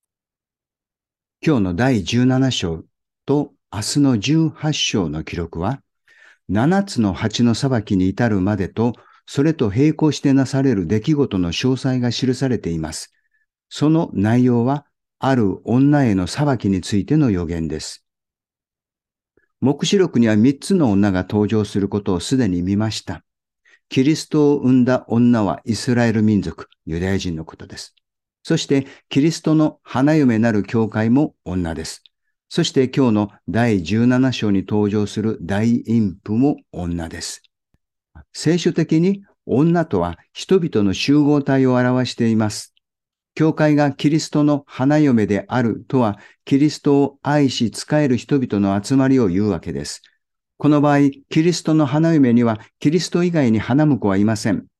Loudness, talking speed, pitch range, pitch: -18 LUFS, 265 characters per minute, 105-145 Hz, 125 Hz